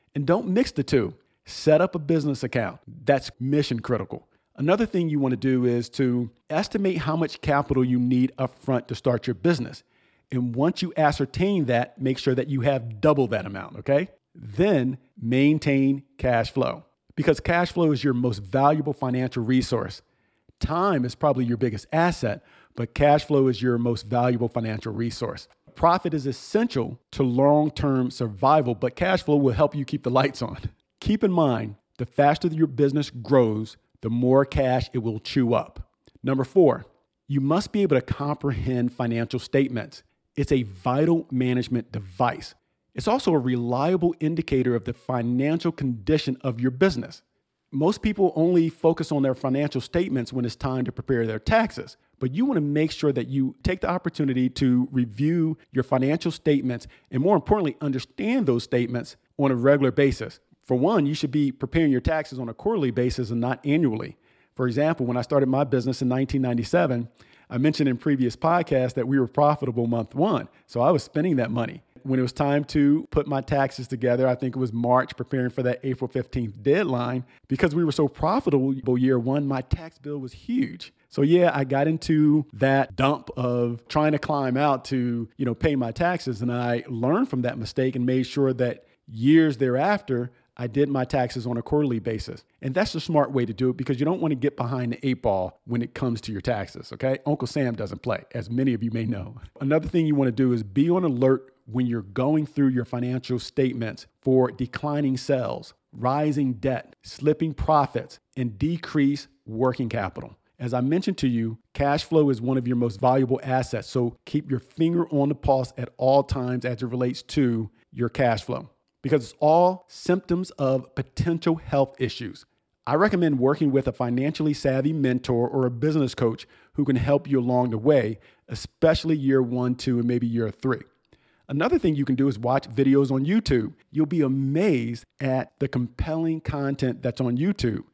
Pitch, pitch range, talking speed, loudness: 130 Hz, 125-150 Hz, 190 wpm, -24 LUFS